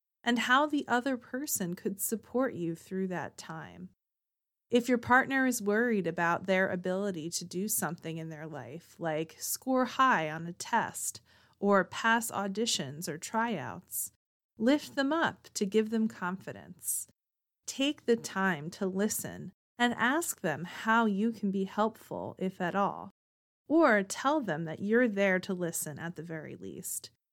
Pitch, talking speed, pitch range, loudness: 200 Hz, 155 wpm, 170-235 Hz, -31 LUFS